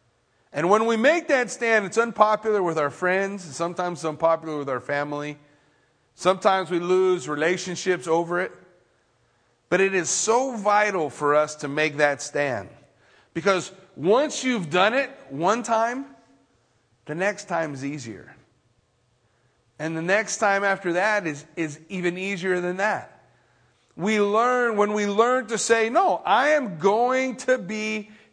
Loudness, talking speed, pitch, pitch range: -23 LUFS, 150 wpm, 185 Hz, 150-215 Hz